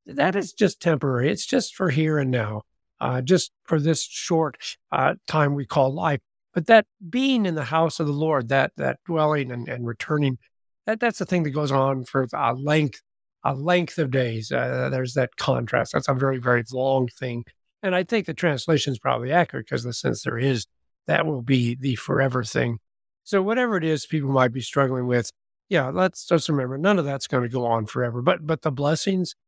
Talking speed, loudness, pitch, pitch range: 210 wpm, -23 LUFS, 140 Hz, 125-165 Hz